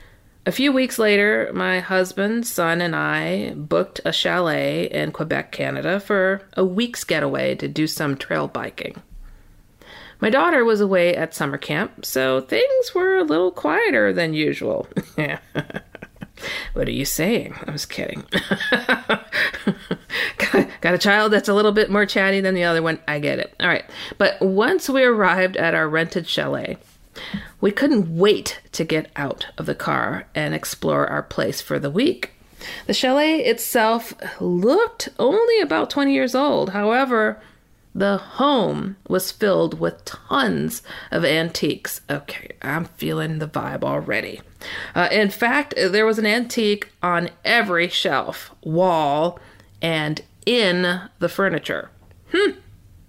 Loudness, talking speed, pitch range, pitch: -20 LUFS, 145 wpm, 160-230 Hz, 190 Hz